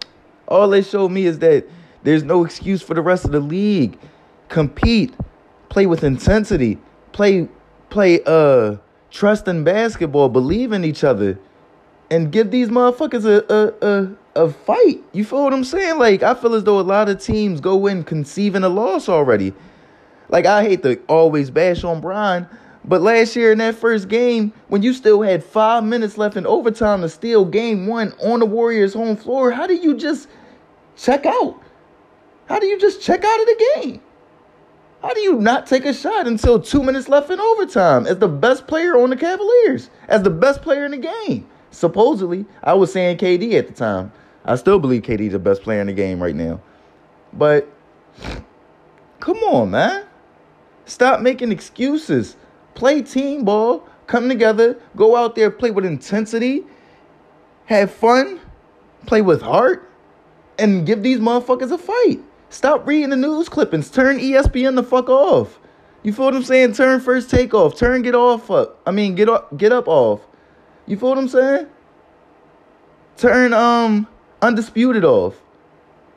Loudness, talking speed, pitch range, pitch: -16 LUFS, 175 wpm, 190-265 Hz, 225 Hz